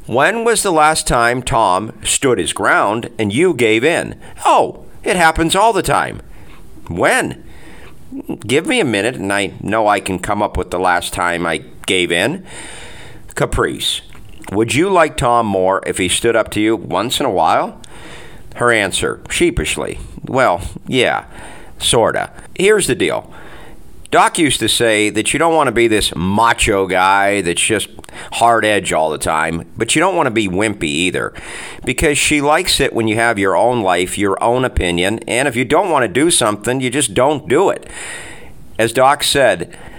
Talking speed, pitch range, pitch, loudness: 180 wpm, 95-125 Hz, 110 Hz, -15 LUFS